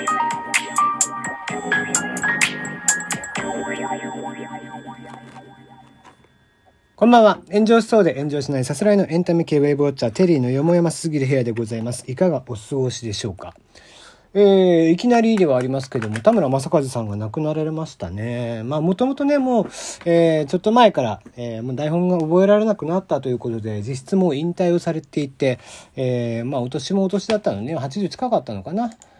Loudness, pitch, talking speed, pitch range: -19 LUFS, 165 Hz, 345 characters per minute, 130-205 Hz